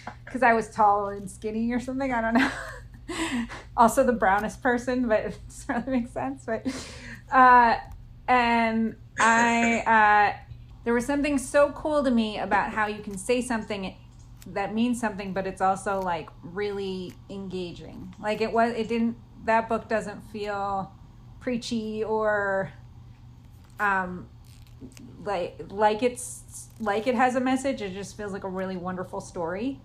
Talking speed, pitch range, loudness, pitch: 150 wpm, 190-240 Hz, -25 LUFS, 215 Hz